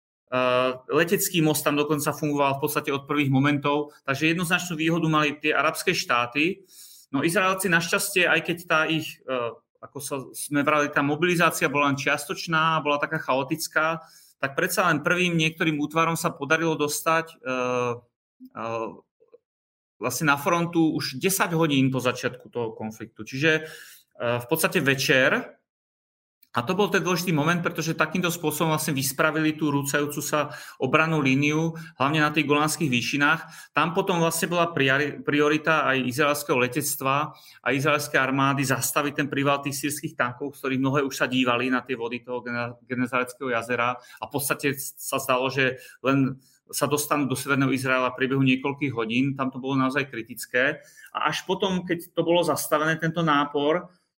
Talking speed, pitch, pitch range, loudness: 160 wpm, 150 Hz, 135-160 Hz, -24 LUFS